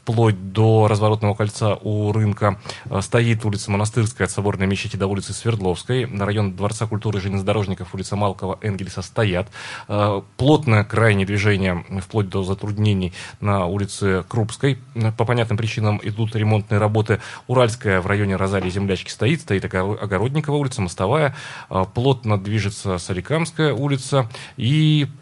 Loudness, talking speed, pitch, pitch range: -21 LUFS, 130 wpm, 105 Hz, 100-115 Hz